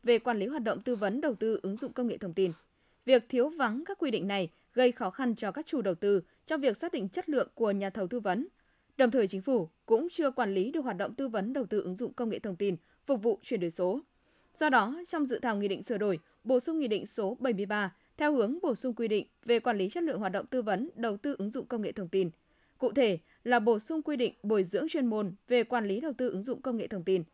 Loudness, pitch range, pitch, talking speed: -31 LUFS, 200-265 Hz, 235 Hz, 280 wpm